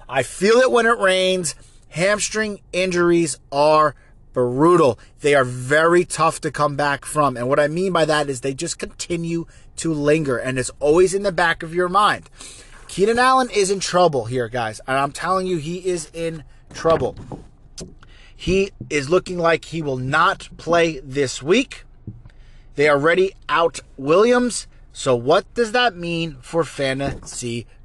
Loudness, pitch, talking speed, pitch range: -19 LUFS, 155 Hz, 165 wpm, 135-180 Hz